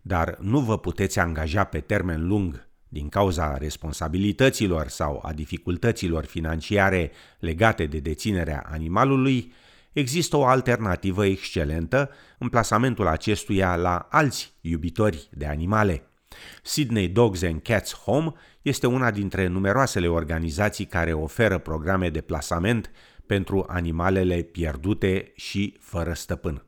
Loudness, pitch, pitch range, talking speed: -24 LUFS, 95 Hz, 80-105 Hz, 115 wpm